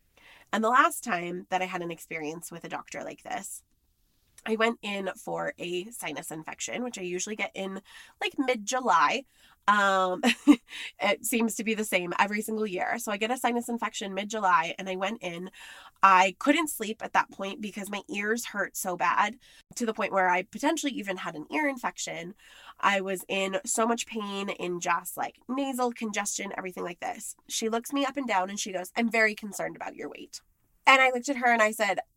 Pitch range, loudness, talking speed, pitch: 185-235 Hz, -28 LUFS, 205 wpm, 210 Hz